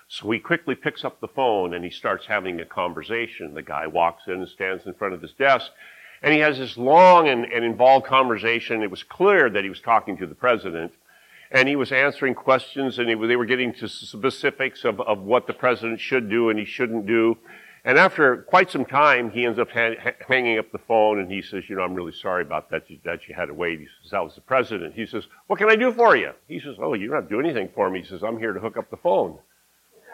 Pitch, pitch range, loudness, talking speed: 120 Hz, 115-135 Hz, -21 LUFS, 255 wpm